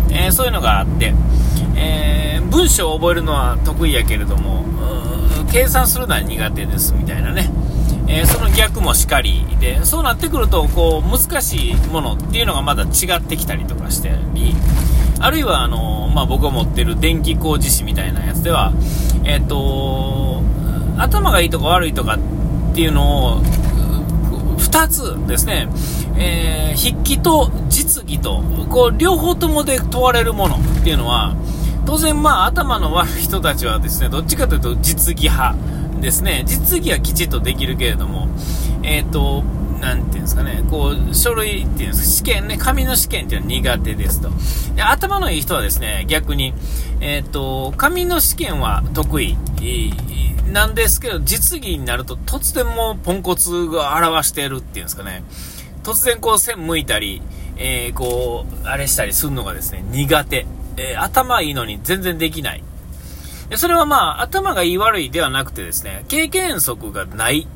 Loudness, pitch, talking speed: -17 LUFS, 90 Hz, 340 characters per minute